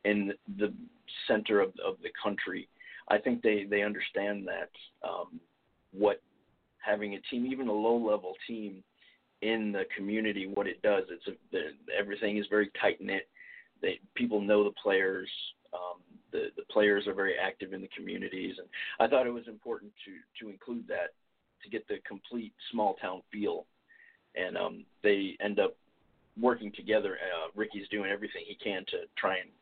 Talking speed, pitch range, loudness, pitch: 165 wpm, 100-120 Hz, -33 LUFS, 105 Hz